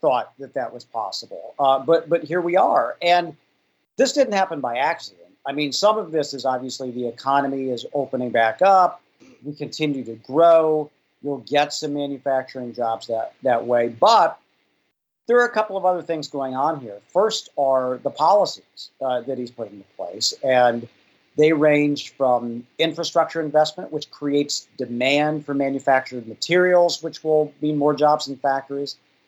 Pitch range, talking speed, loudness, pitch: 130-160 Hz, 170 wpm, -21 LUFS, 145 Hz